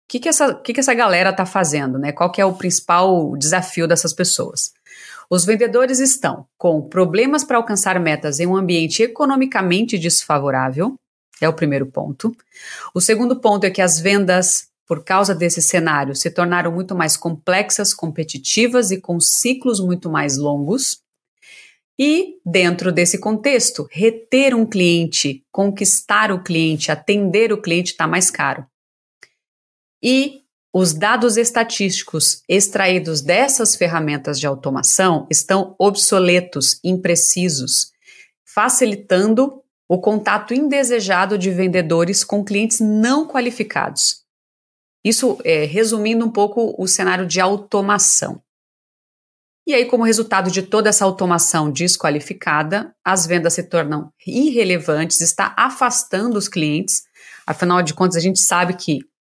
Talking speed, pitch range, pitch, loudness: 130 wpm, 170-225 Hz, 190 Hz, -16 LUFS